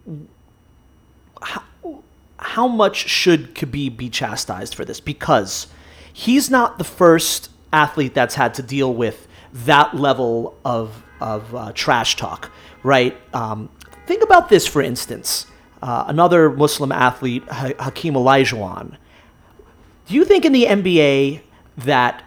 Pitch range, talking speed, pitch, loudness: 120-165 Hz, 130 wpm, 135 Hz, -17 LUFS